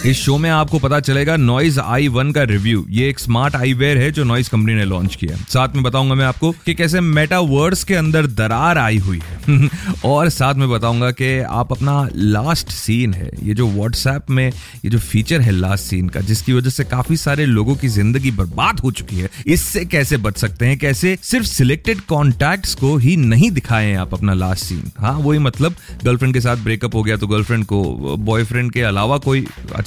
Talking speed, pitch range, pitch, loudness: 205 wpm, 110-145 Hz, 130 Hz, -16 LUFS